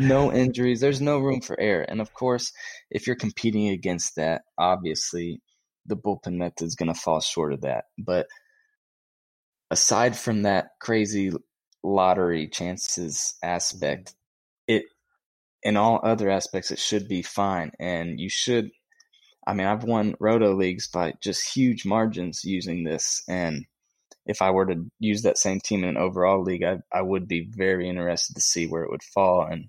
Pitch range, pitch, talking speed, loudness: 90-115 Hz, 95 Hz, 170 wpm, -25 LUFS